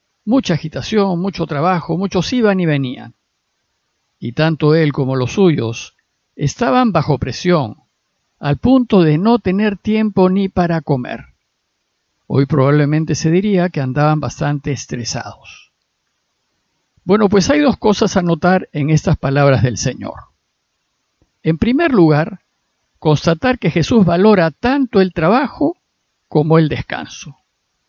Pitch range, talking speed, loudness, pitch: 145-200 Hz, 125 wpm, -15 LUFS, 165 Hz